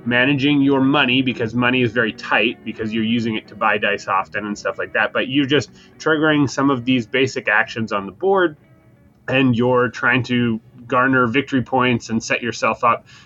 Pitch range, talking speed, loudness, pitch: 115-135 Hz, 195 wpm, -18 LUFS, 125 Hz